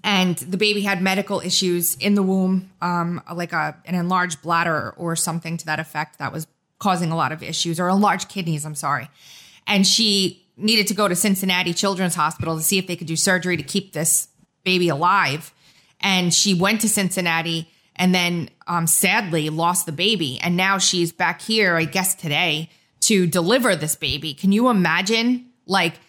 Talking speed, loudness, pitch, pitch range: 185 wpm, -20 LUFS, 175 Hz, 165-195 Hz